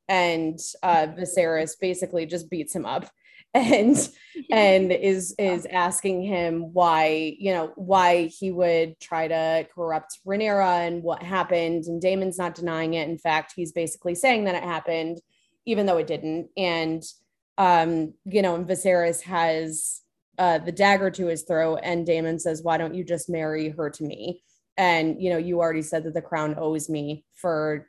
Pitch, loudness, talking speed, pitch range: 170 Hz, -24 LUFS, 170 wpm, 160-185 Hz